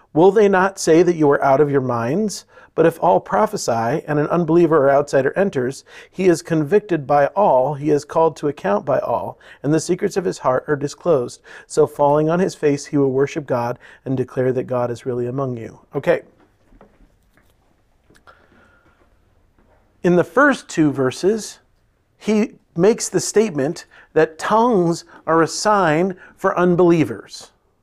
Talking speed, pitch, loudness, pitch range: 160 wpm, 155 Hz, -18 LUFS, 130-180 Hz